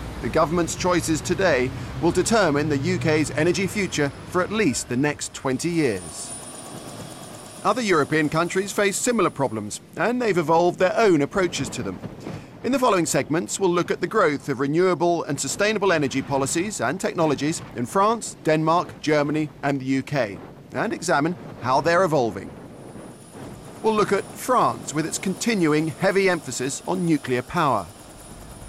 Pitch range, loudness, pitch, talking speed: 140-185 Hz, -22 LUFS, 160 Hz, 150 wpm